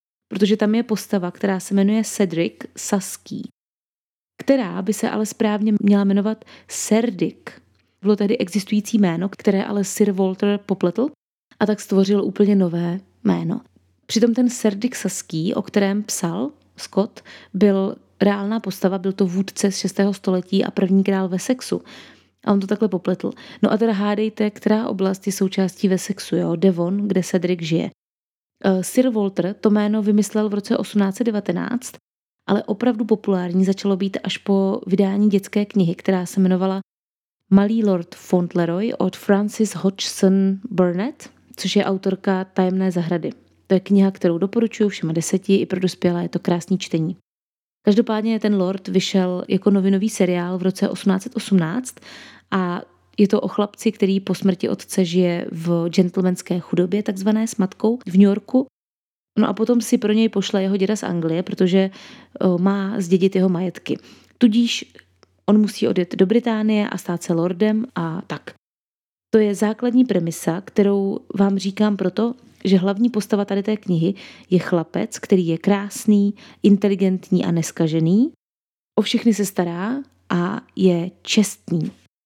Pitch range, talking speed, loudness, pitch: 185-215 Hz, 150 wpm, -20 LUFS, 200 Hz